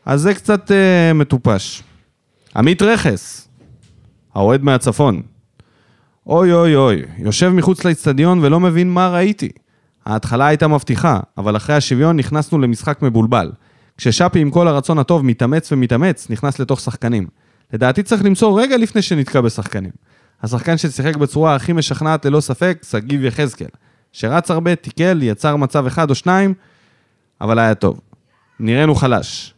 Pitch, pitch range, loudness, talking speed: 145 Hz, 120-170 Hz, -15 LUFS, 135 wpm